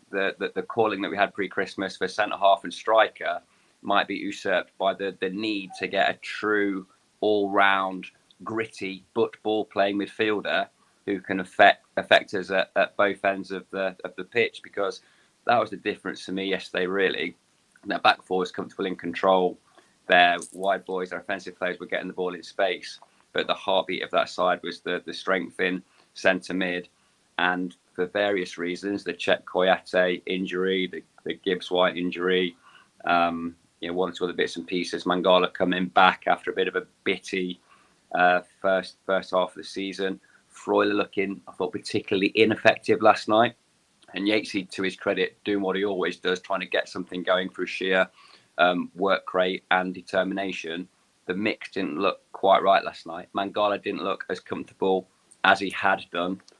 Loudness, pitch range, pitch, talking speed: -25 LUFS, 90-100 Hz, 95 Hz, 180 wpm